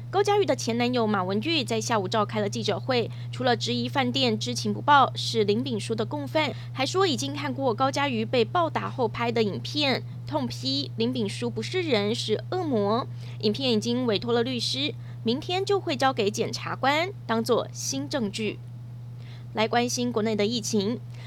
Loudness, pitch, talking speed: -26 LUFS, 130 Hz, 270 characters per minute